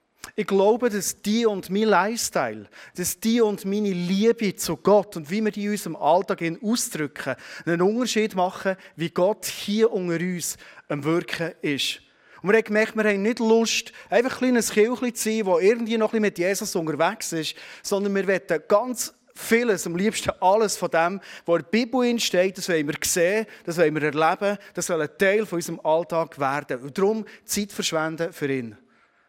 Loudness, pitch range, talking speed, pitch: -23 LUFS, 170-215 Hz, 185 wpm, 195 Hz